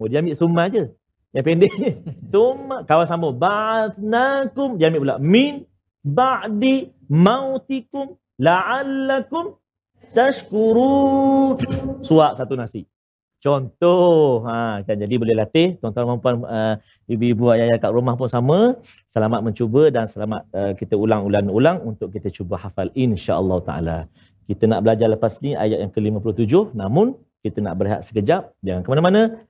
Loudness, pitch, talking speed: -19 LUFS, 130 Hz, 135 wpm